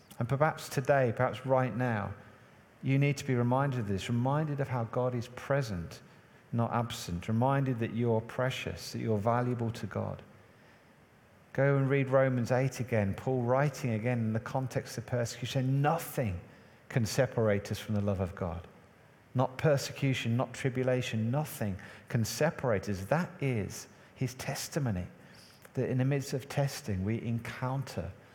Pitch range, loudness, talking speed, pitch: 110-135 Hz, -32 LUFS, 155 wpm, 125 Hz